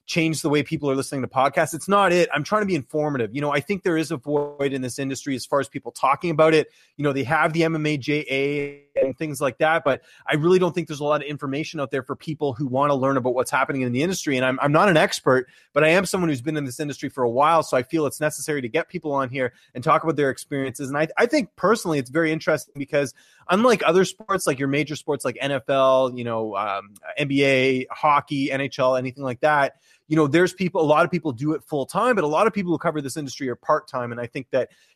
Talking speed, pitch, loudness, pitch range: 270 wpm, 145 Hz, -22 LUFS, 135-160 Hz